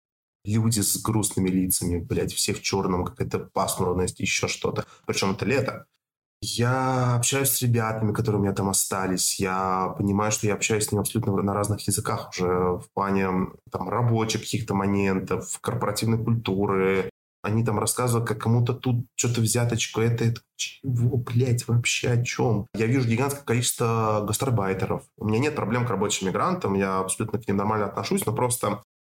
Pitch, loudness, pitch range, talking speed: 105 Hz, -25 LUFS, 95-120 Hz, 165 wpm